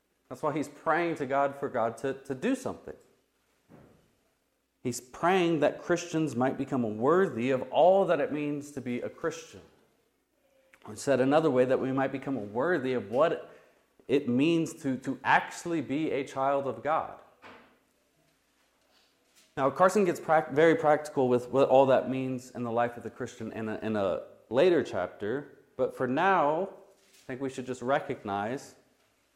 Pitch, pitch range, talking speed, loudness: 135 Hz, 125-160 Hz, 165 wpm, -29 LUFS